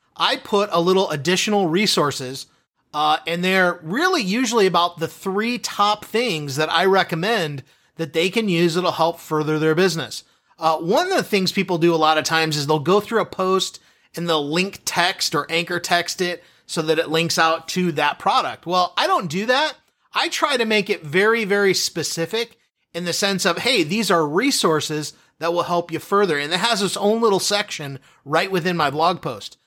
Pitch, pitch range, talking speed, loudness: 175 Hz, 160-200 Hz, 200 wpm, -20 LUFS